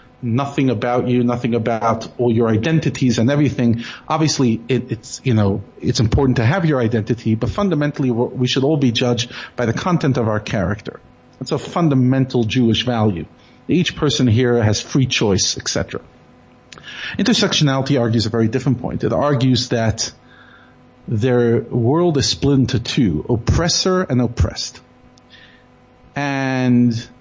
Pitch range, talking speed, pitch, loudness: 115-135 Hz, 145 wpm, 125 Hz, -18 LUFS